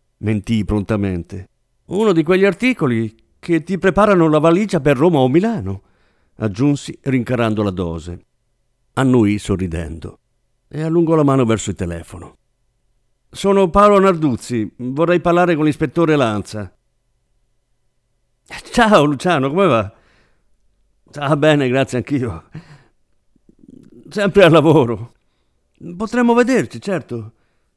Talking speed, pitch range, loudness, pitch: 110 wpm, 105-170 Hz, -16 LUFS, 130 Hz